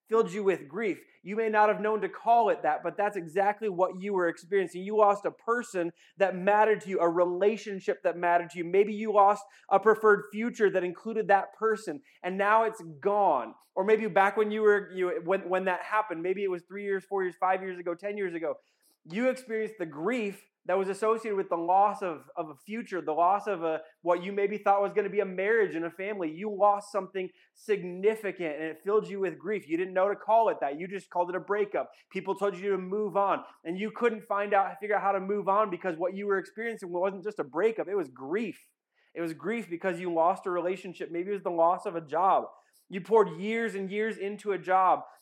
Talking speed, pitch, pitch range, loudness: 240 wpm, 195 Hz, 180-210 Hz, -29 LUFS